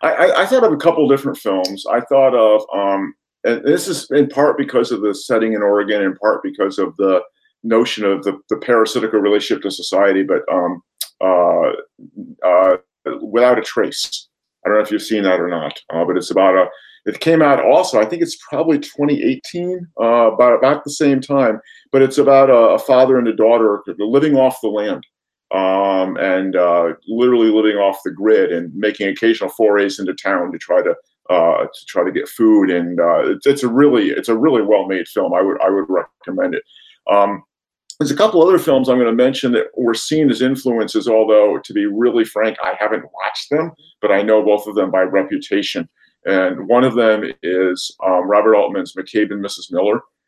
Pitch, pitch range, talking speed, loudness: 115 Hz, 100-145 Hz, 200 wpm, -15 LUFS